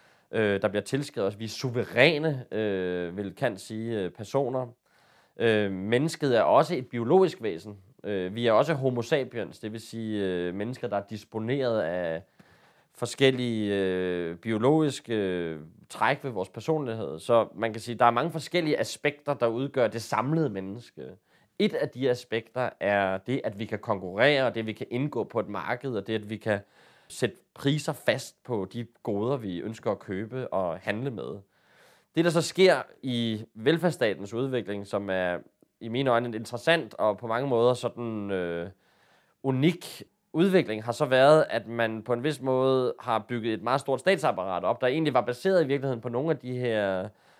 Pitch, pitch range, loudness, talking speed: 115 Hz, 105-135 Hz, -28 LUFS, 180 wpm